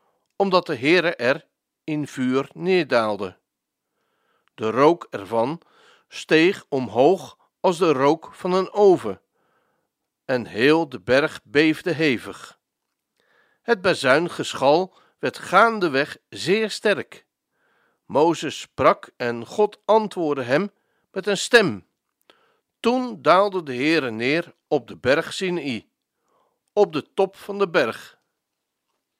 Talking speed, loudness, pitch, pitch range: 110 wpm, -21 LUFS, 185 Hz, 145-210 Hz